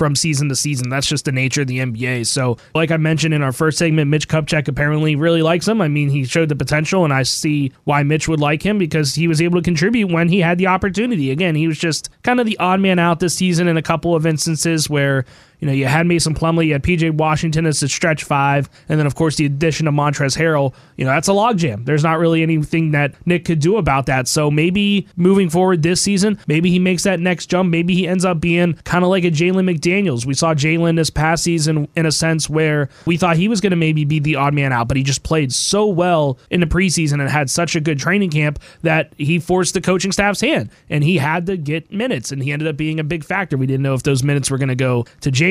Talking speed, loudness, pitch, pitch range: 265 wpm, -16 LUFS, 160 Hz, 145-175 Hz